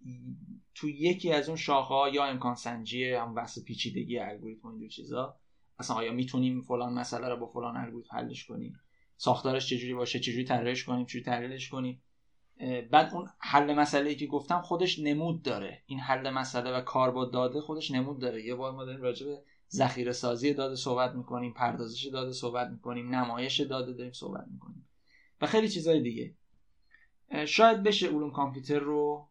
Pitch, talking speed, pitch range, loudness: 130 Hz, 165 wpm, 125-145 Hz, -31 LUFS